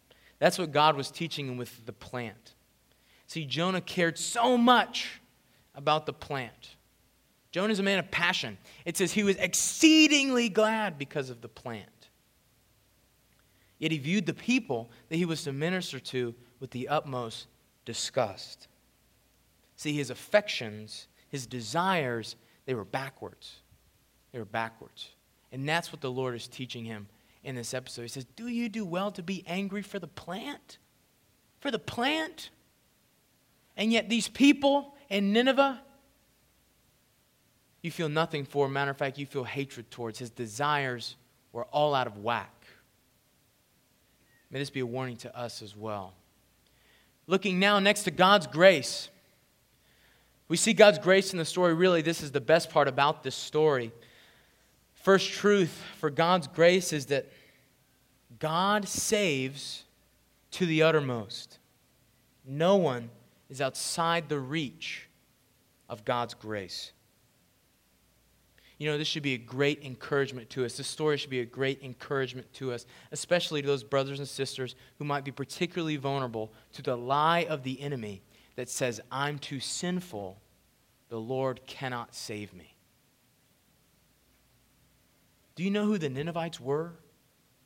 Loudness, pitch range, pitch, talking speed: -29 LUFS, 125-175 Hz, 140 Hz, 145 wpm